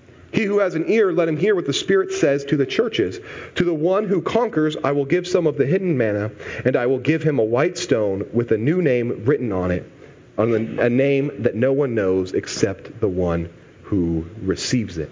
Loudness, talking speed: -20 LUFS, 220 wpm